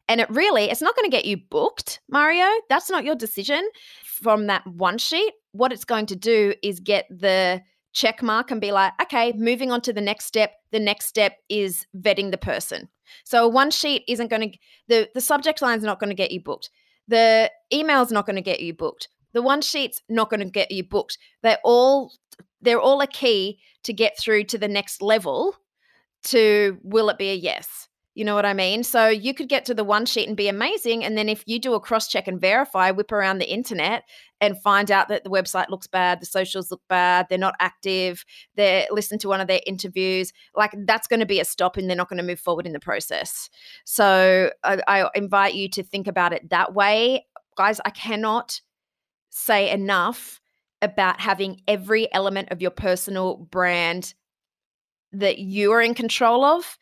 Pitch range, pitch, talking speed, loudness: 190-235 Hz, 210 Hz, 210 wpm, -21 LUFS